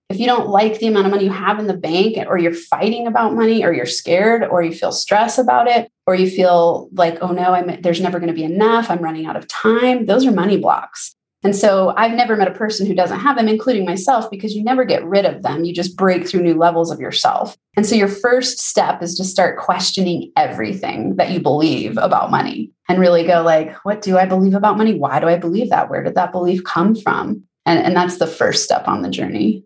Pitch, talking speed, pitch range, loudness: 195 Hz, 245 wpm, 175-220 Hz, -16 LUFS